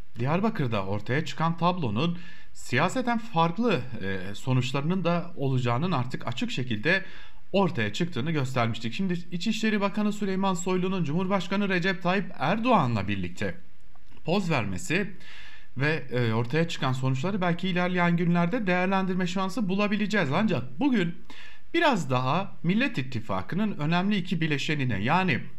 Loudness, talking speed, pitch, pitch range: -27 LUFS, 110 wpm, 170 Hz, 125-190 Hz